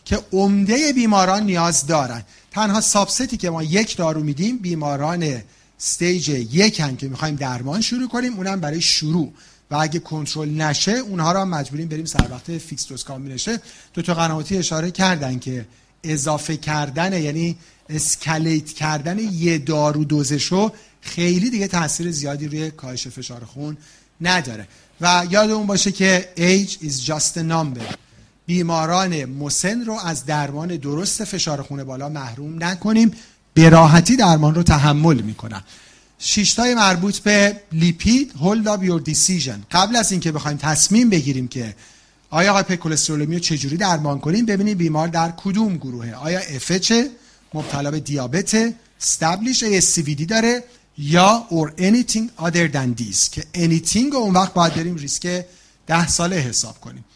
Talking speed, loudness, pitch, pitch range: 145 wpm, -18 LUFS, 165 Hz, 150-195 Hz